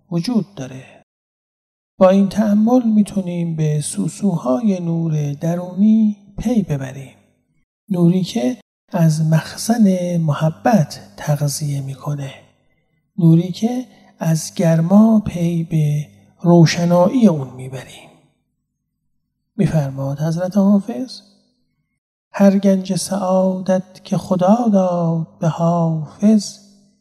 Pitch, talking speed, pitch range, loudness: 180 Hz, 85 wpm, 160-205 Hz, -17 LUFS